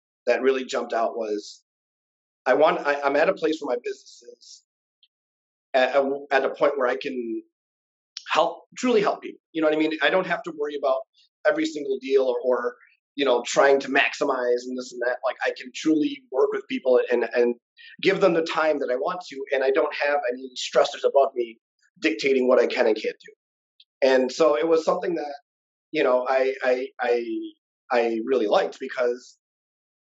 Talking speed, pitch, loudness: 200 wpm, 145 Hz, -23 LUFS